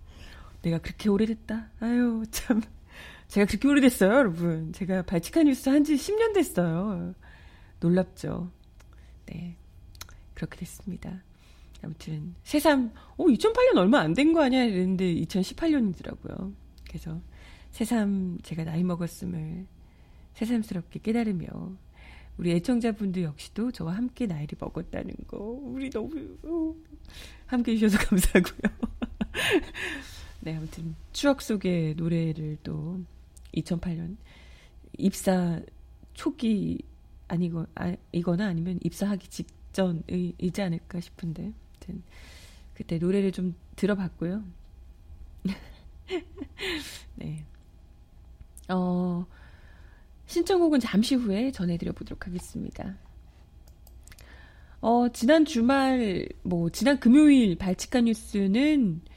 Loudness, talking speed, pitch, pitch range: -27 LUFS, 230 characters per minute, 190 Hz, 170-235 Hz